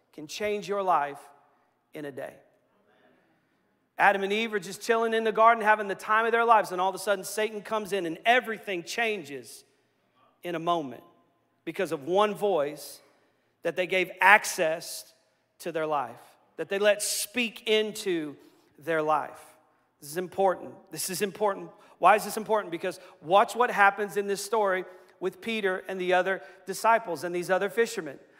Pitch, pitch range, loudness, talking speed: 190 Hz, 175-210 Hz, -27 LUFS, 170 wpm